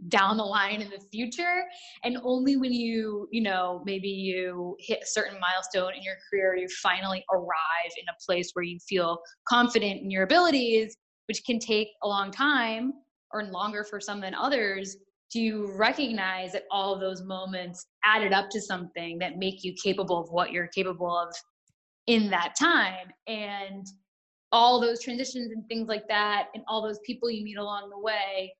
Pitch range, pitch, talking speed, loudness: 185-225 Hz, 200 Hz, 185 wpm, -28 LUFS